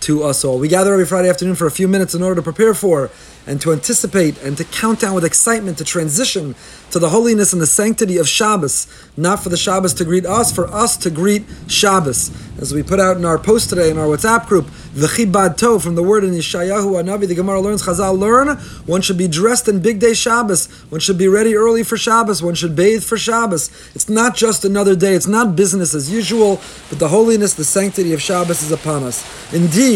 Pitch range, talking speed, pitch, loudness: 170-215 Hz, 230 wpm, 190 Hz, -14 LUFS